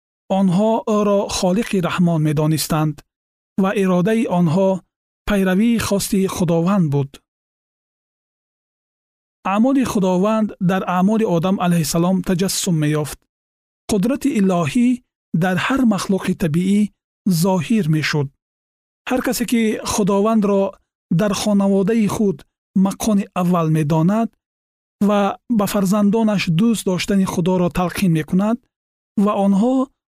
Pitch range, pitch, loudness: 175-215 Hz, 195 Hz, -18 LUFS